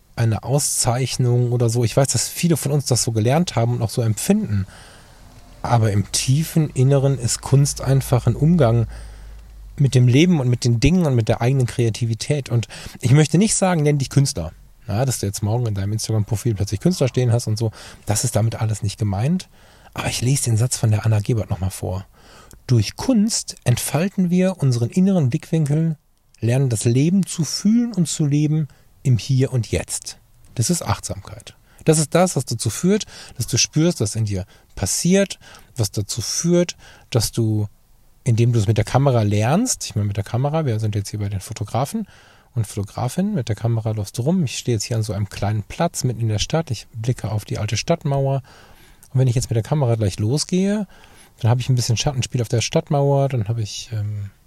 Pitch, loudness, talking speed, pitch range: 120 Hz, -20 LUFS, 205 wpm, 110-145 Hz